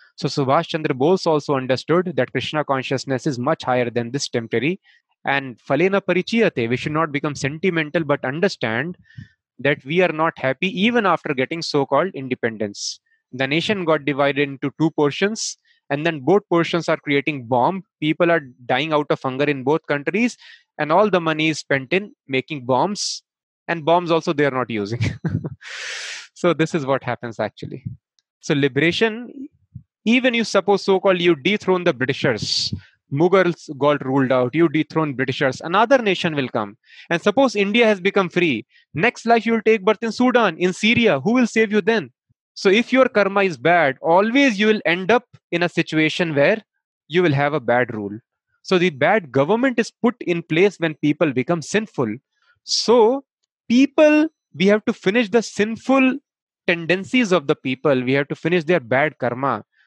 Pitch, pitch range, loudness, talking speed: 170 Hz, 140-205 Hz, -19 LUFS, 175 wpm